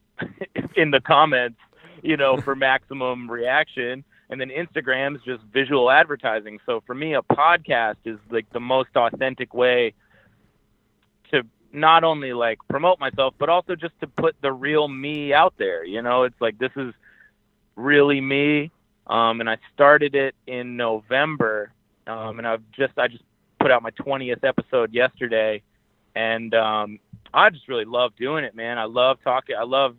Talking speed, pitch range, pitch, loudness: 165 wpm, 115-140 Hz, 125 Hz, -21 LUFS